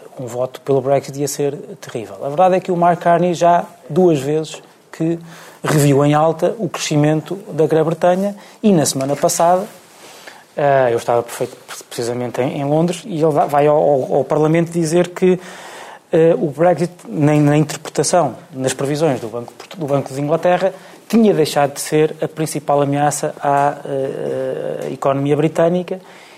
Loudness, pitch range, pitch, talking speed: -16 LUFS, 140-175 Hz, 155 Hz, 140 wpm